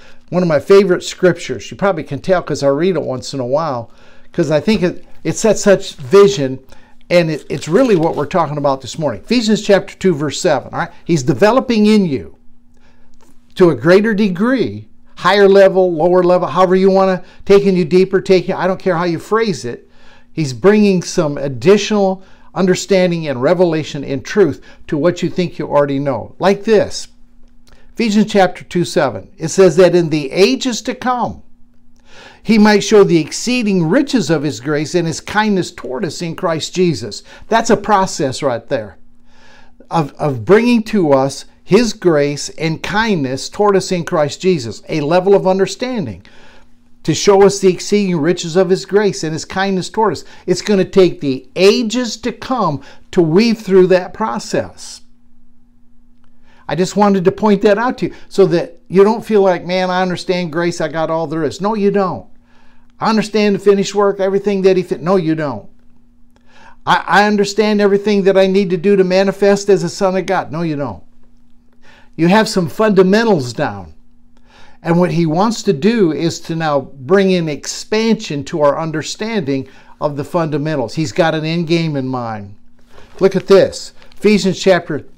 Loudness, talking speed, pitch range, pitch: -14 LUFS, 185 wpm, 145-195 Hz, 180 Hz